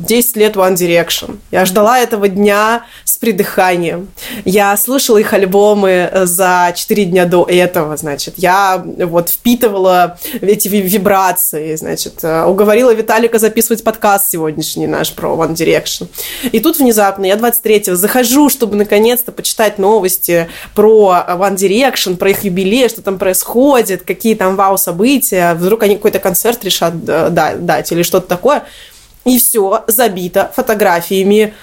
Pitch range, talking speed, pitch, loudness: 180-225 Hz, 135 wpm, 200 Hz, -11 LUFS